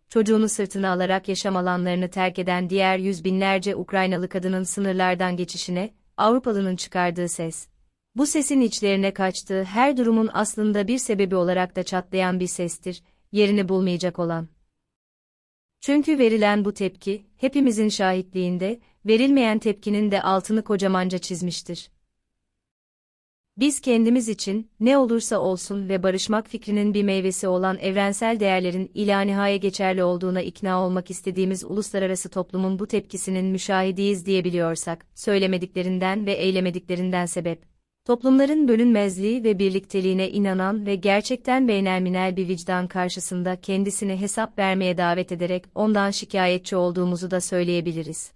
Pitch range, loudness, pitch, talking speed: 185-210 Hz, -23 LUFS, 190 Hz, 120 wpm